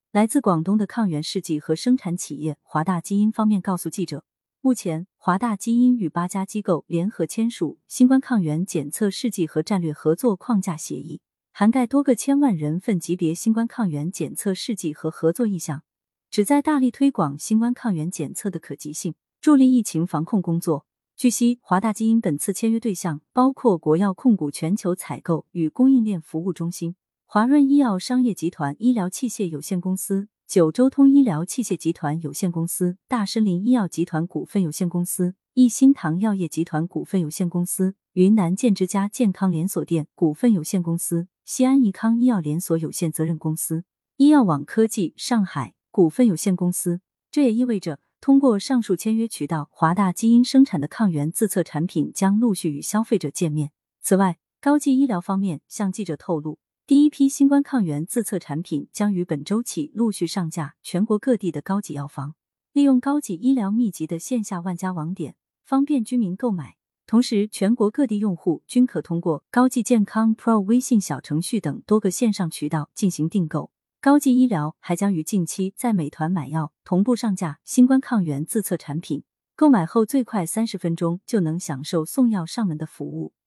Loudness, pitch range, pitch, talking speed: -22 LUFS, 165-235 Hz, 190 Hz, 295 characters per minute